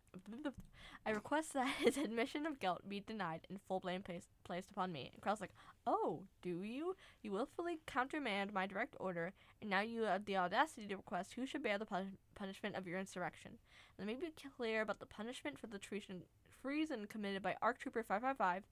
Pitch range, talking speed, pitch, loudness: 185-250 Hz, 195 wpm, 205 Hz, -43 LUFS